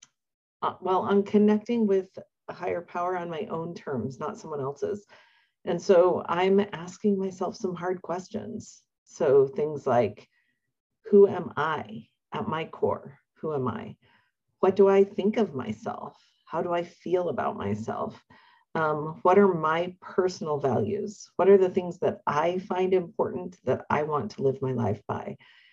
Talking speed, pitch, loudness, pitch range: 160 wpm, 185 Hz, -27 LUFS, 175-205 Hz